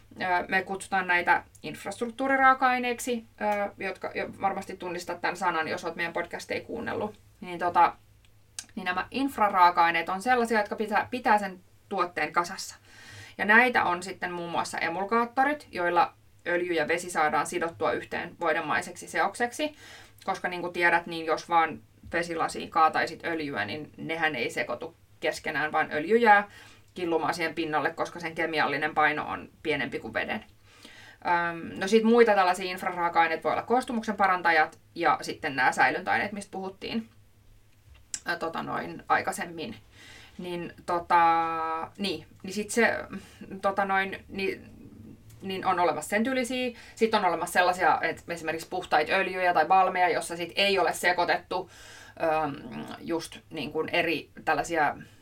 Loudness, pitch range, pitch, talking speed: -27 LUFS, 160-200 Hz, 175 Hz, 140 wpm